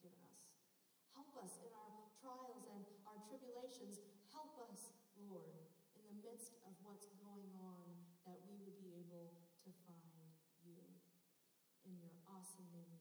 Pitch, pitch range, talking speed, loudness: 195 Hz, 175-220 Hz, 135 wpm, -61 LUFS